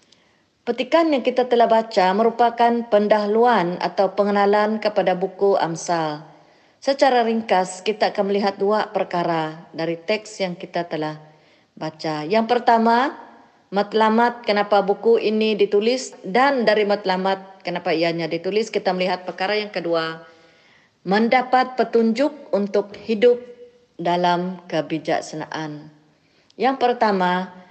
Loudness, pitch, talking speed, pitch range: -20 LUFS, 205 Hz, 110 wpm, 175-230 Hz